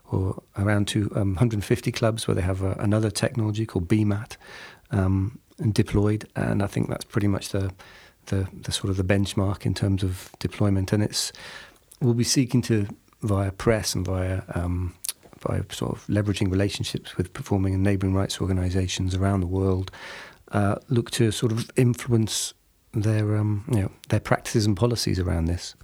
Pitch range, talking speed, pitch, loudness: 95-115 Hz, 175 wpm, 100 Hz, -25 LUFS